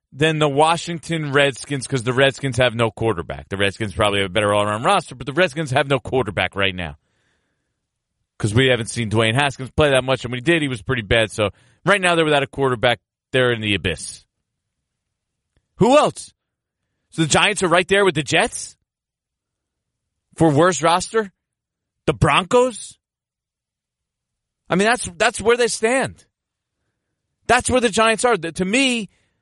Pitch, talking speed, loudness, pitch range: 135 Hz, 175 wpm, -18 LUFS, 115-175 Hz